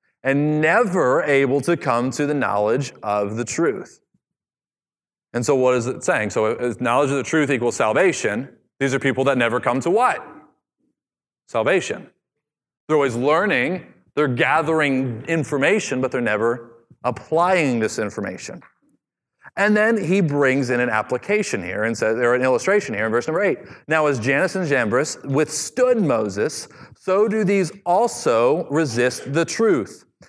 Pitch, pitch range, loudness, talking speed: 140 Hz, 125-175 Hz, -20 LUFS, 155 wpm